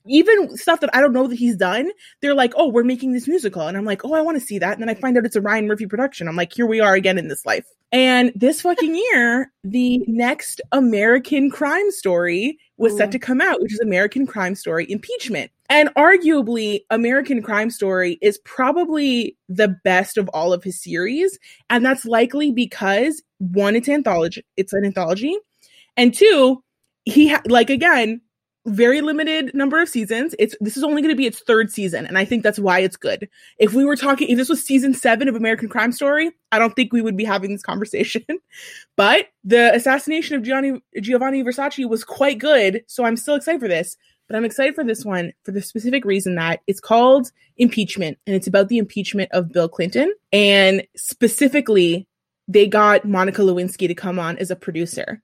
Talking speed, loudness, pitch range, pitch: 205 wpm, -18 LUFS, 200-275 Hz, 235 Hz